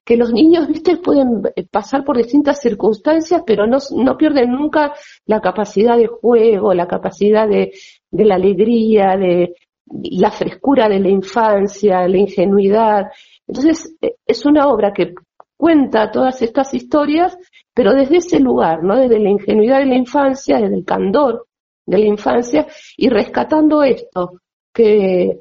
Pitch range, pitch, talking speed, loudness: 205-290 Hz, 235 Hz, 145 wpm, -14 LUFS